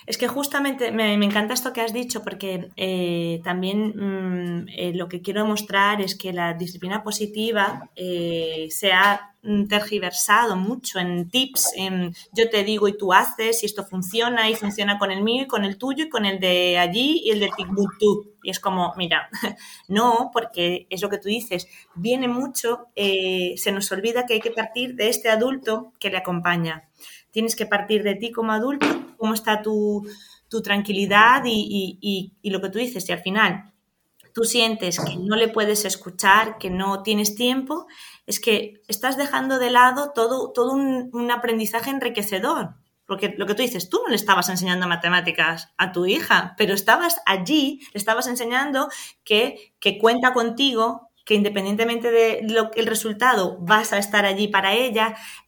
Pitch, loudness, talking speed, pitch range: 210 Hz, -21 LUFS, 180 wpm, 190-230 Hz